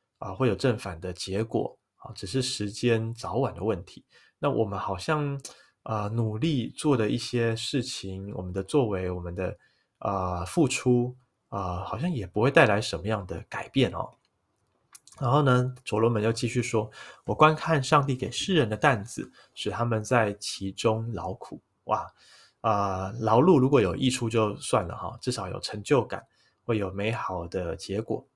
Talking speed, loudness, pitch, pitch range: 250 characters per minute, -27 LUFS, 110 Hz, 100-130 Hz